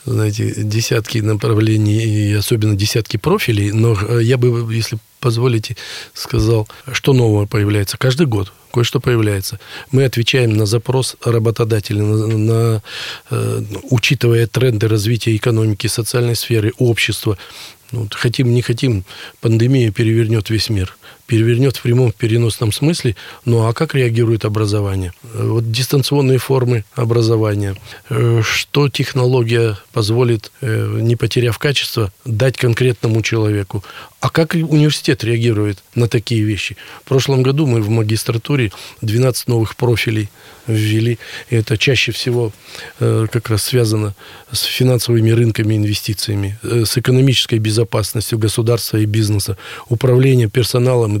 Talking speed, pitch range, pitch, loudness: 120 wpm, 110-125 Hz, 115 Hz, -16 LUFS